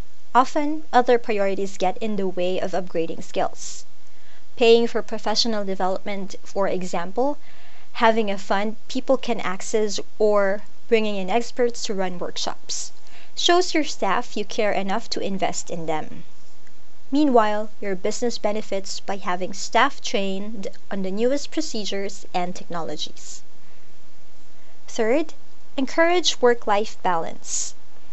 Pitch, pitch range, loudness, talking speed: 215 Hz, 195-245 Hz, -23 LUFS, 125 wpm